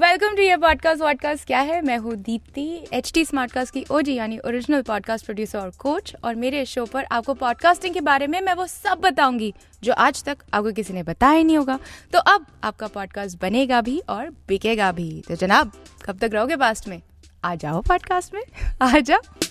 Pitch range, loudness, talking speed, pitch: 215-315 Hz, -21 LUFS, 195 wpm, 260 Hz